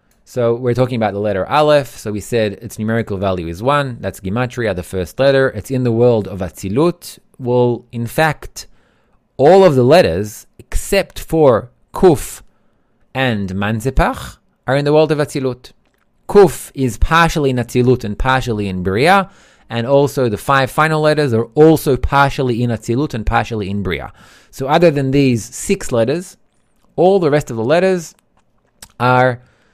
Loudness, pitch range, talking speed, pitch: -15 LUFS, 110-145 Hz, 165 wpm, 125 Hz